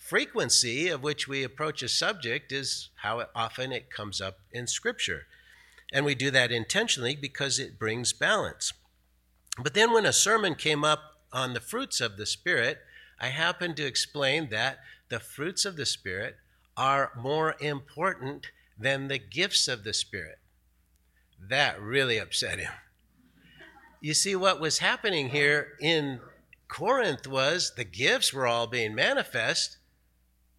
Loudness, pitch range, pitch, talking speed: -27 LUFS, 115-150 Hz, 135 Hz, 145 wpm